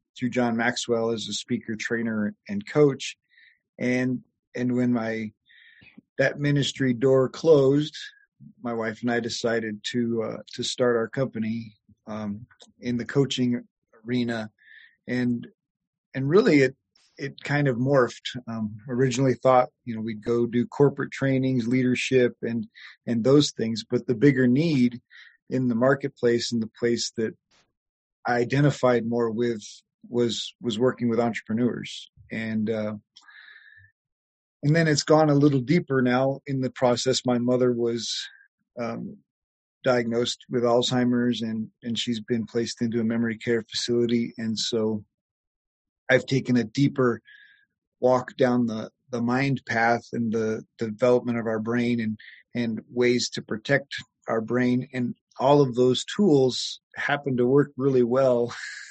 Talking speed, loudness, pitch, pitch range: 145 wpm, -25 LUFS, 120 Hz, 115-130 Hz